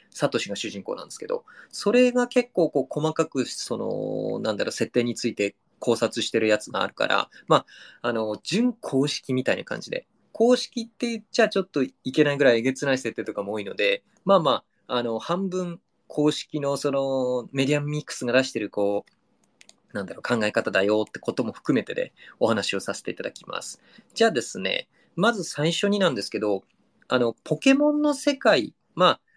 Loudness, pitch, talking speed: -25 LUFS, 155 Hz, 370 characters per minute